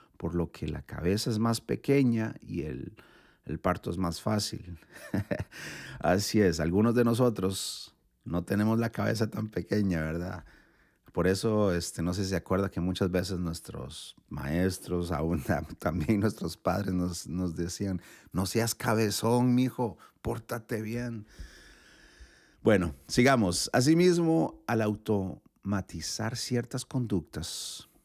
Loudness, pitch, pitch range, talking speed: -30 LUFS, 100 Hz, 90-115 Hz, 130 wpm